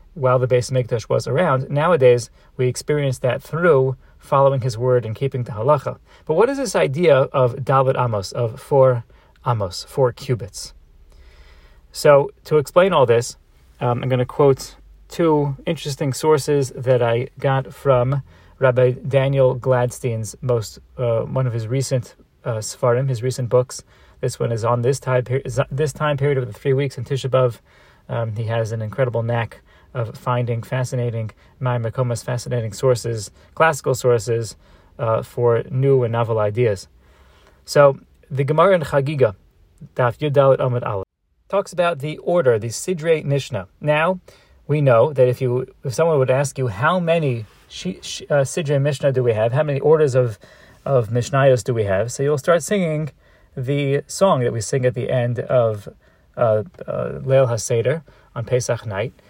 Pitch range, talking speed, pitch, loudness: 115-140 Hz, 160 wpm, 130 Hz, -19 LUFS